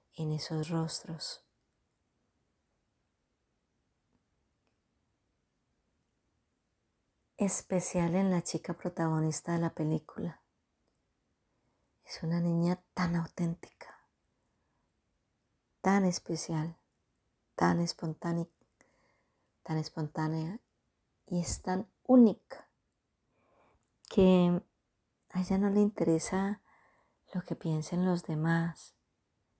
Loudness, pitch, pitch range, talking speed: -32 LUFS, 170 Hz, 160-185 Hz, 75 wpm